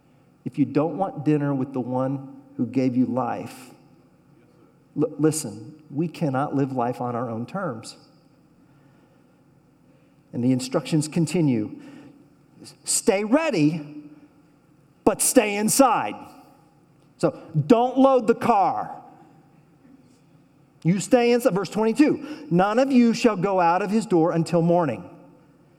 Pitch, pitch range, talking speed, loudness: 155 Hz, 140-195 Hz, 120 wpm, -22 LUFS